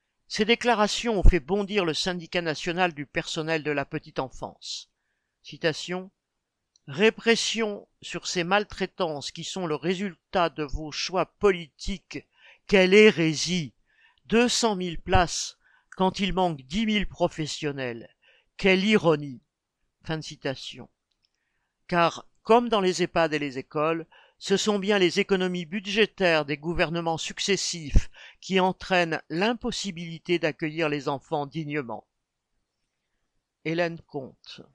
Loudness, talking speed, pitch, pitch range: -26 LUFS, 120 wpm, 175 Hz, 155-195 Hz